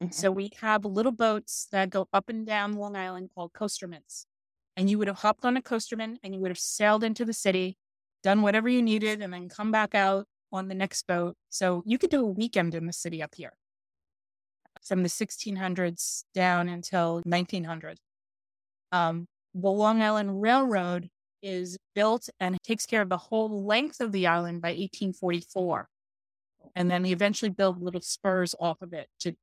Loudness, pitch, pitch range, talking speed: -28 LUFS, 190 Hz, 175-215 Hz, 185 wpm